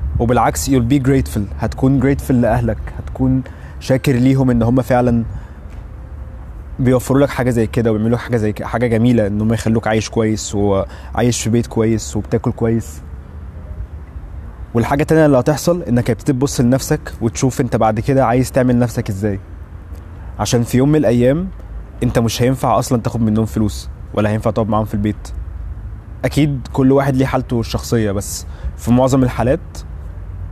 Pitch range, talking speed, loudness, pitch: 90-125 Hz, 155 wpm, -16 LUFS, 115 Hz